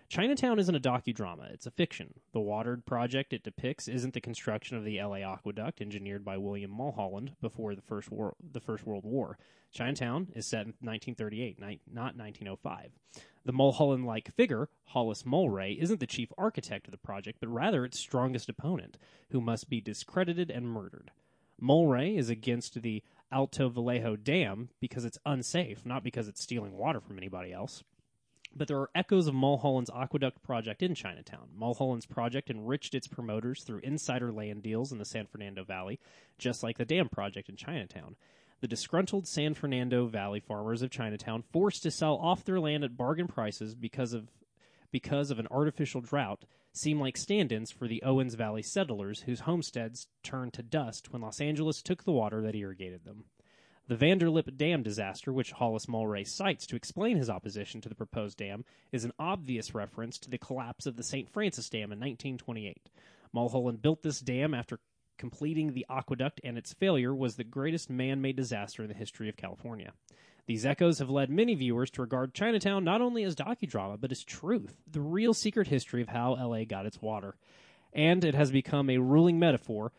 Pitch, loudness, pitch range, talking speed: 125 Hz, -33 LUFS, 110-150 Hz, 185 wpm